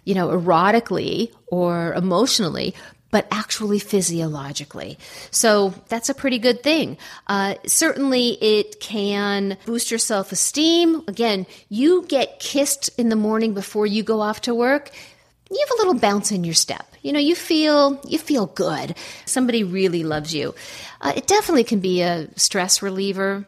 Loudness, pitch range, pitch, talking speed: -20 LUFS, 195-260 Hz, 215 Hz, 155 wpm